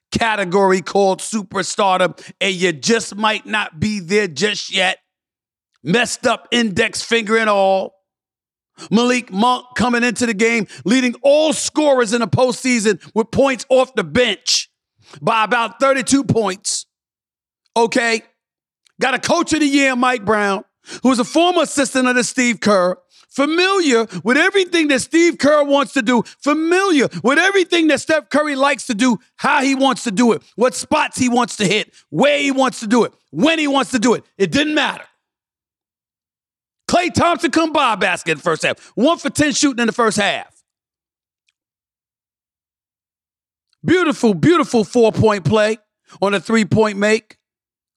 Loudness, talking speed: -16 LUFS, 160 wpm